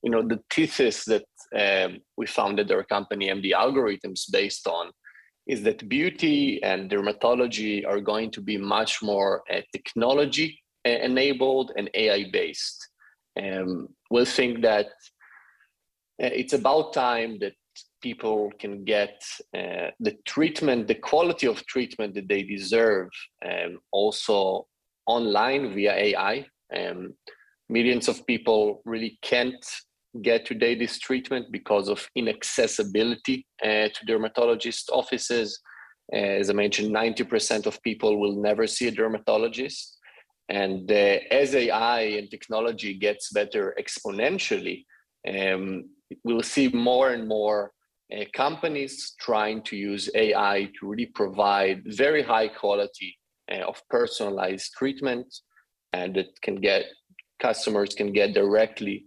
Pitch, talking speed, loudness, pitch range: 110 Hz, 130 wpm, -25 LUFS, 105-130 Hz